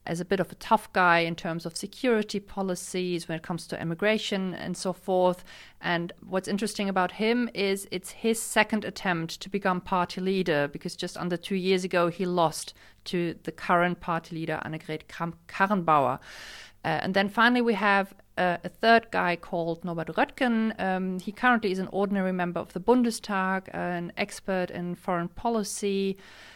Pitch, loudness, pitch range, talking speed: 185 Hz, -27 LUFS, 175-205 Hz, 175 wpm